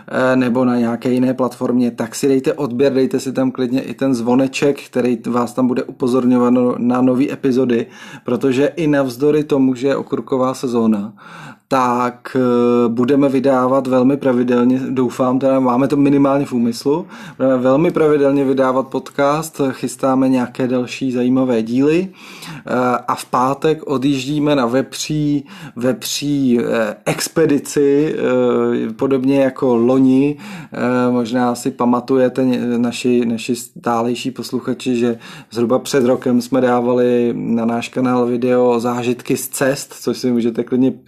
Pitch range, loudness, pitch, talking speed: 125-135 Hz, -16 LUFS, 130 Hz, 130 wpm